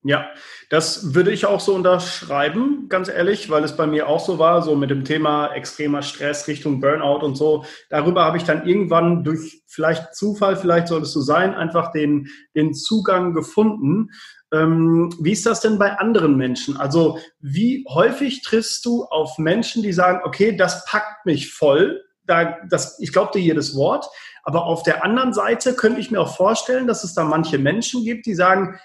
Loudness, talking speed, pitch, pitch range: -19 LUFS, 190 wpm, 170 Hz, 155-205 Hz